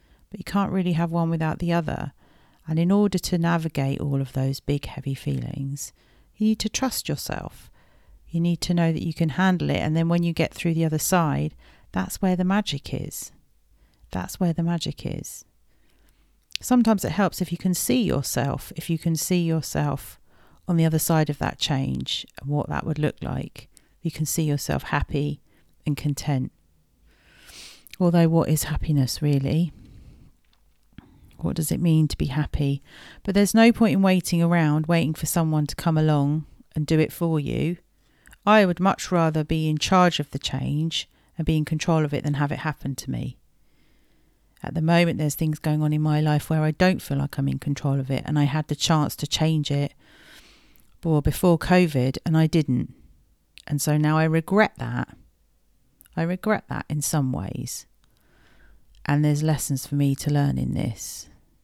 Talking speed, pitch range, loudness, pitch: 185 wpm, 140-170 Hz, -24 LUFS, 155 Hz